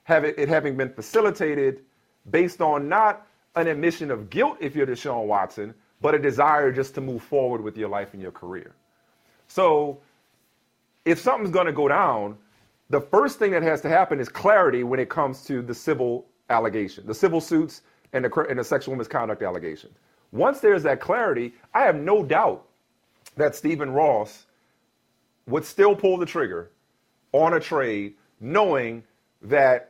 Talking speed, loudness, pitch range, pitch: 170 wpm, -23 LUFS, 115-165 Hz, 140 Hz